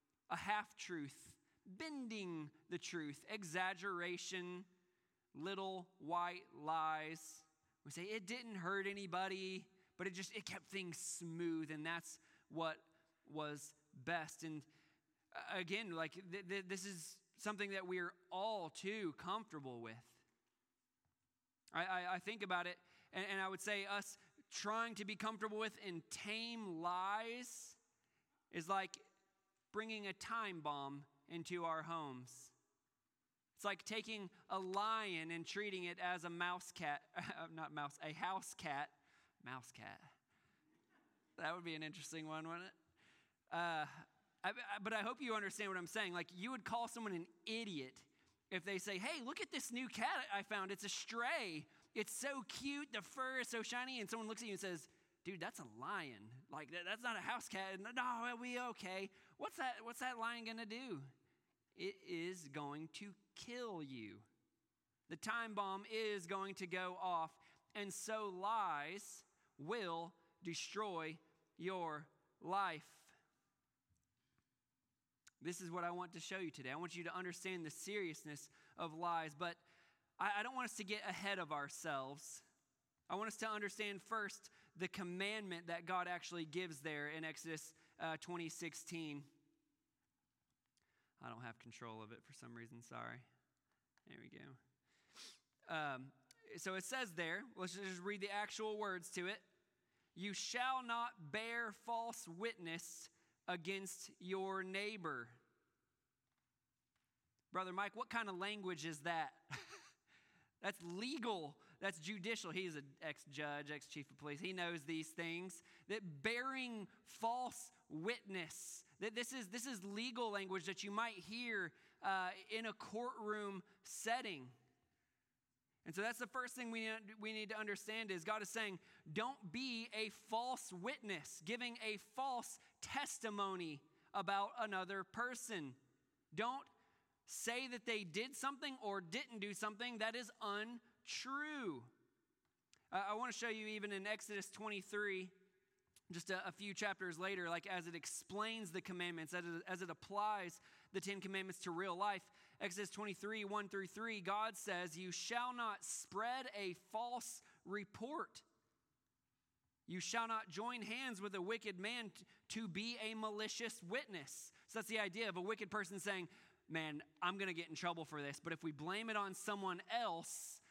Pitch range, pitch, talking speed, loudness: 170-220 Hz, 195 Hz, 155 wpm, -46 LUFS